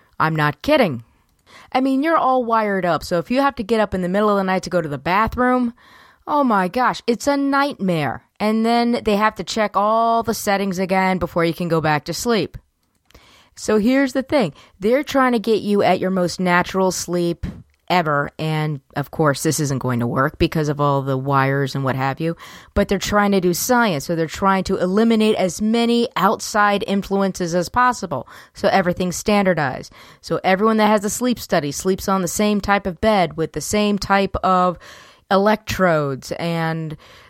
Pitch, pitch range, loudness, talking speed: 190 Hz, 165-220 Hz, -19 LUFS, 200 wpm